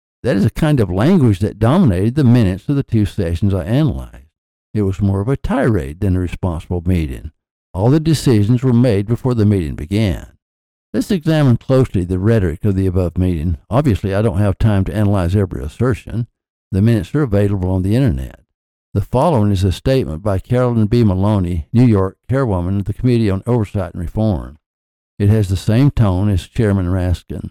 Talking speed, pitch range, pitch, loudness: 190 wpm, 90-120 Hz, 100 Hz, -16 LUFS